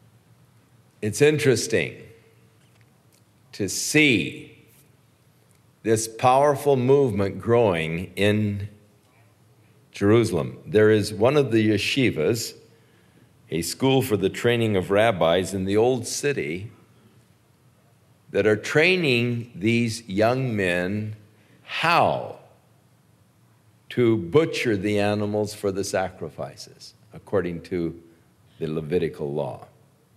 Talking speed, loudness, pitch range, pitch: 90 wpm, -22 LUFS, 100-125 Hz, 110 Hz